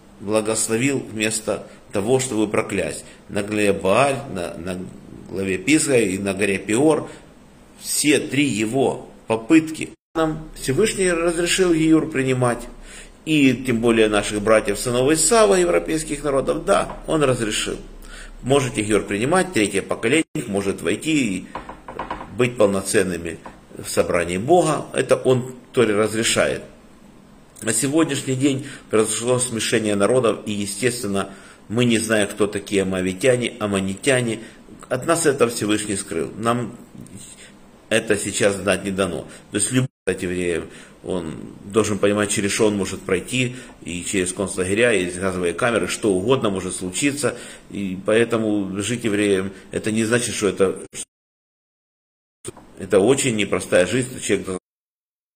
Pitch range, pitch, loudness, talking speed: 100-130 Hz, 110 Hz, -20 LUFS, 125 wpm